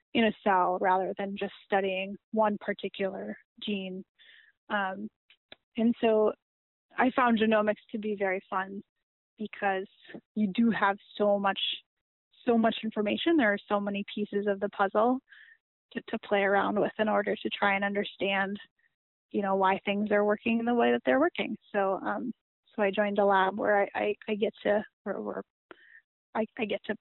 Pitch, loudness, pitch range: 205 Hz, -29 LUFS, 195-220 Hz